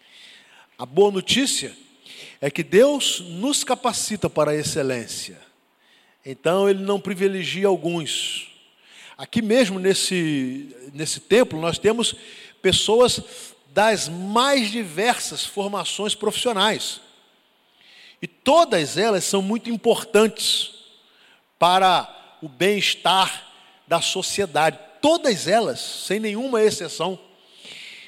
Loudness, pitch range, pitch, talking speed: -21 LUFS, 170-225 Hz, 200 Hz, 95 wpm